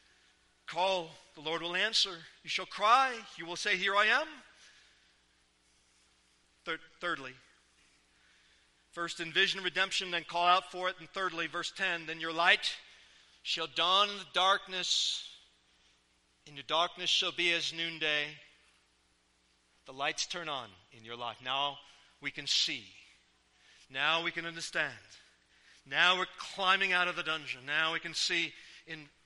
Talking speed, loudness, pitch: 140 wpm, -31 LUFS, 160 Hz